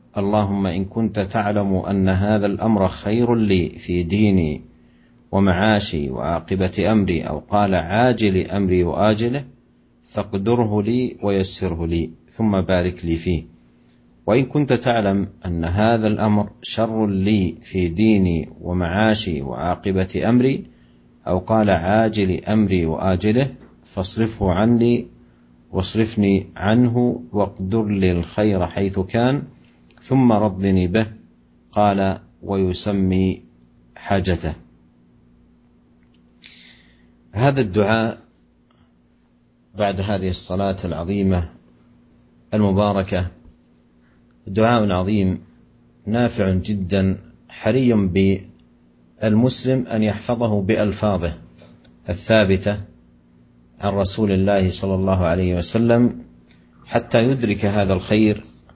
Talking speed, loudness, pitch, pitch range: 90 wpm, -20 LUFS, 95 Hz, 80-105 Hz